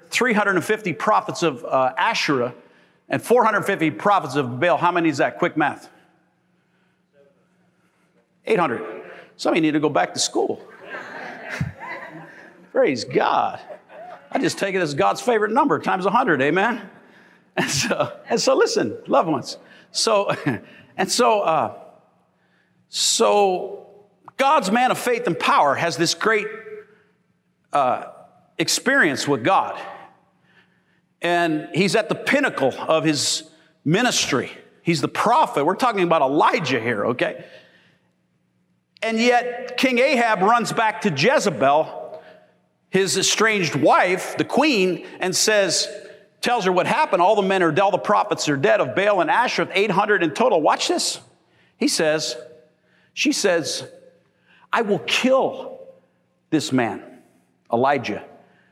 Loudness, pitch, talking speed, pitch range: -20 LUFS, 185 Hz, 130 wpm, 165-220 Hz